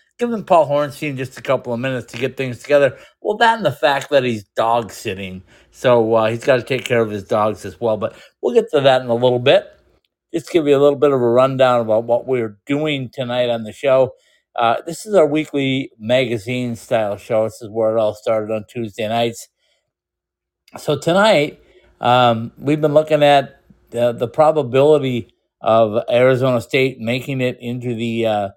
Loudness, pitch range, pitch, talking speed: -17 LUFS, 115-135 Hz, 125 Hz, 200 wpm